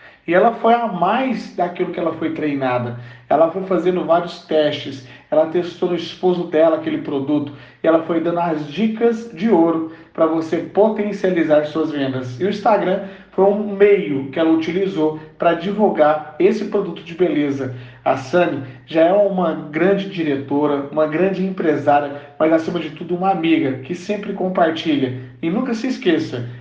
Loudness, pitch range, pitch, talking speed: -18 LUFS, 150-190 Hz, 165 Hz, 165 wpm